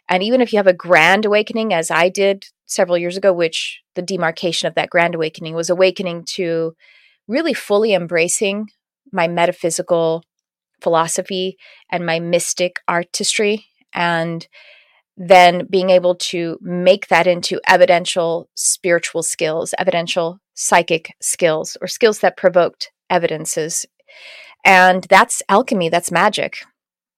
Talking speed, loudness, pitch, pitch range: 130 wpm, -16 LUFS, 180 Hz, 170-195 Hz